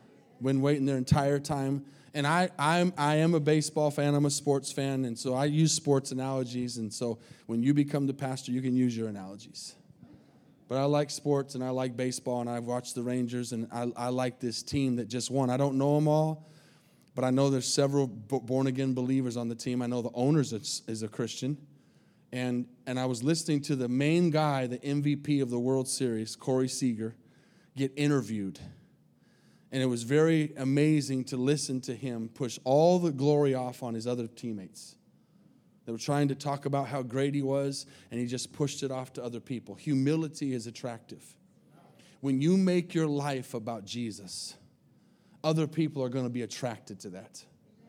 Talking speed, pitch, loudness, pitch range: 195 wpm, 135 Hz, -30 LUFS, 125-145 Hz